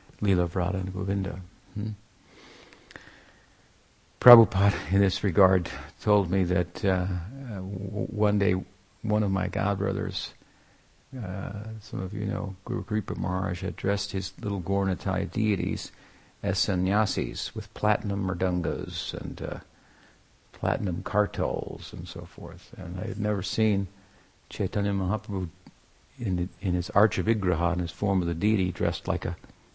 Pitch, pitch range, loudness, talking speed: 95 Hz, 90-105 Hz, -27 LUFS, 135 wpm